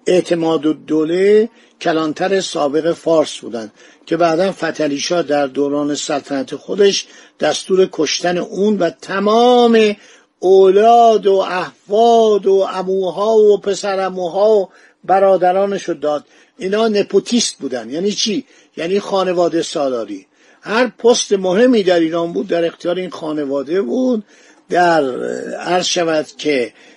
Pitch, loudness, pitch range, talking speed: 185 Hz, -15 LUFS, 165-205 Hz, 120 wpm